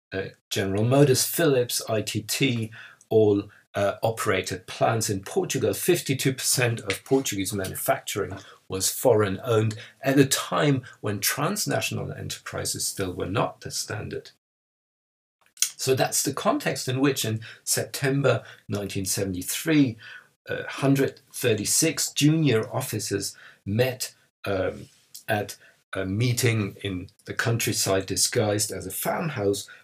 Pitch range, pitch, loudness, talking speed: 100-135 Hz, 110 Hz, -25 LUFS, 110 wpm